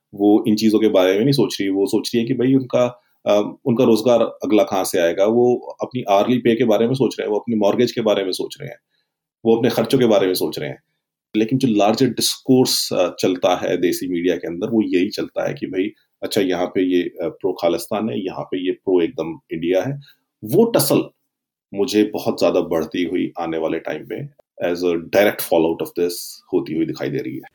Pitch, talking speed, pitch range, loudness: 110 Hz, 225 wpm, 95-125 Hz, -19 LUFS